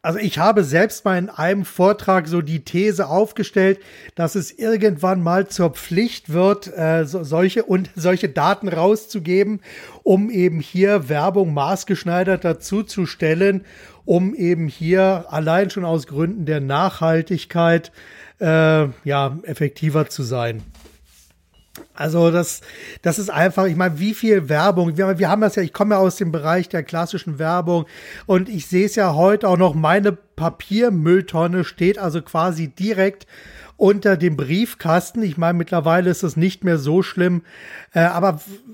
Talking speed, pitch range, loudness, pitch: 155 wpm, 165-195 Hz, -18 LUFS, 180 Hz